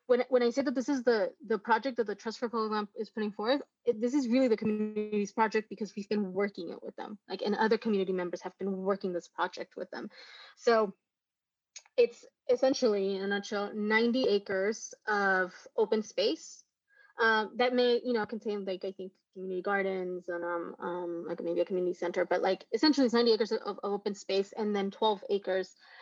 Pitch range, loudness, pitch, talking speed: 195-240 Hz, -31 LUFS, 215 Hz, 205 wpm